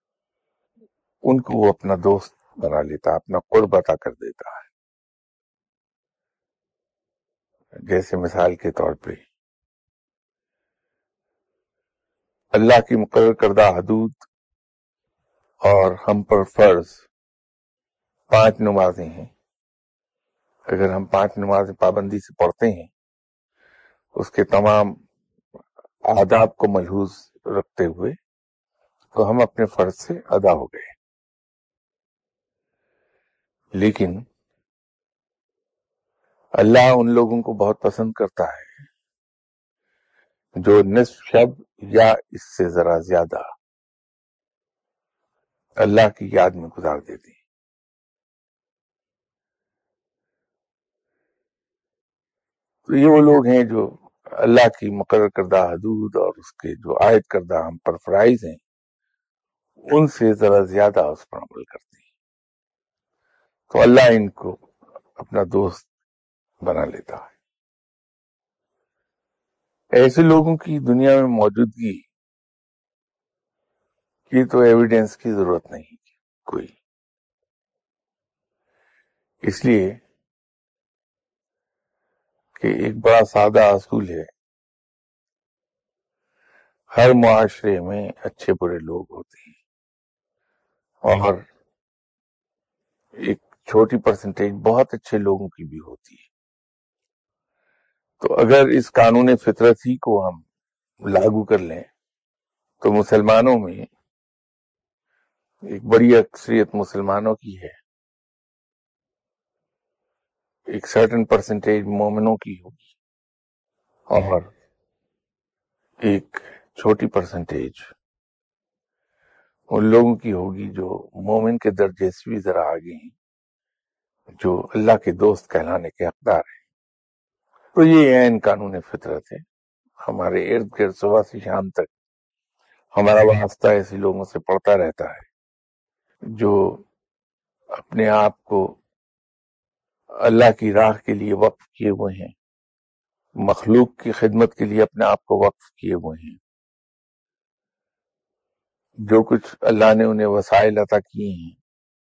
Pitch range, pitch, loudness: 100-130 Hz, 110 Hz, -17 LUFS